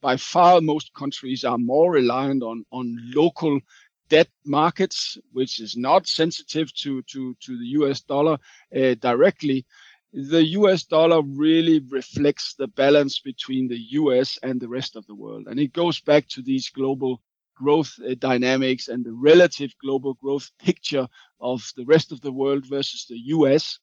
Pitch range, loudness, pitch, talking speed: 130-155 Hz, -21 LUFS, 135 Hz, 165 wpm